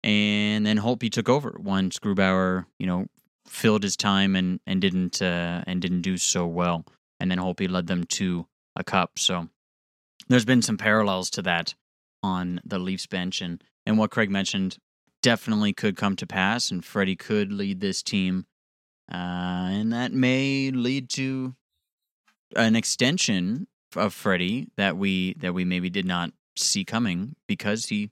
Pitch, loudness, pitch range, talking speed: 95 Hz, -25 LUFS, 90-115 Hz, 165 wpm